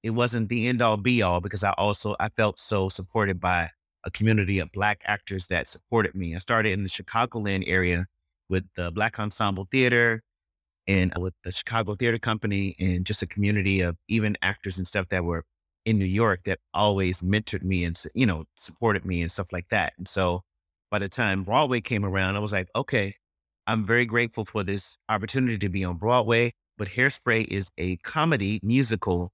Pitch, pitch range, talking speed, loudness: 100 Hz, 90-110 Hz, 195 wpm, -26 LUFS